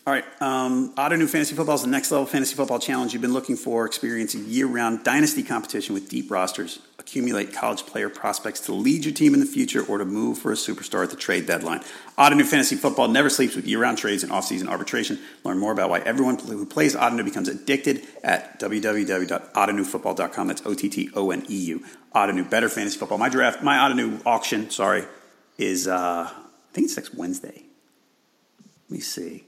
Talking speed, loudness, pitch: 200 wpm, -23 LUFS, 140 Hz